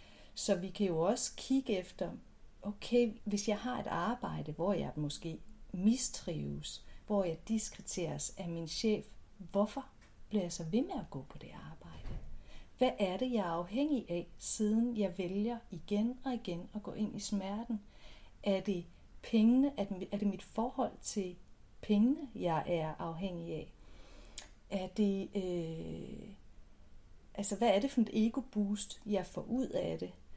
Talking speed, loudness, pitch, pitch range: 160 wpm, -36 LUFS, 200 Hz, 175-225 Hz